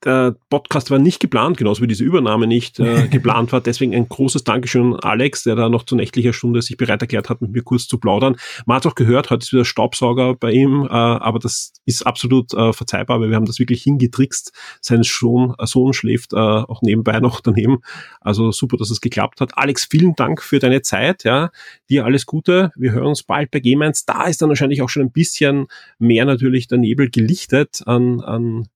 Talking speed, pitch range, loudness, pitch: 215 wpm, 115-135 Hz, -16 LUFS, 125 Hz